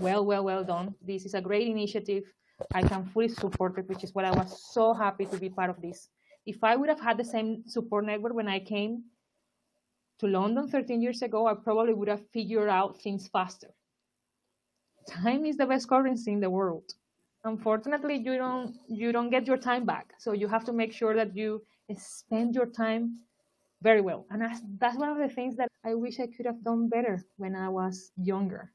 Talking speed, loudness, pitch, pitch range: 205 wpm, -30 LUFS, 220 Hz, 195-235 Hz